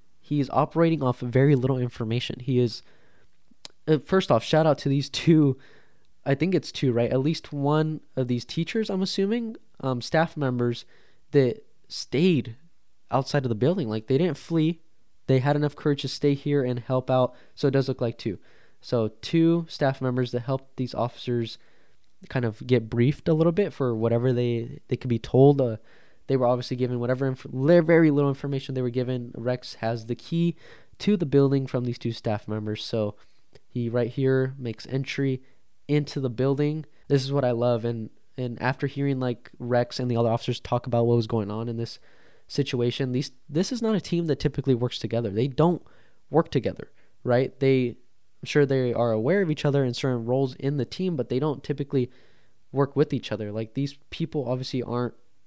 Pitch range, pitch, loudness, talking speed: 120-145 Hz, 130 Hz, -25 LUFS, 195 wpm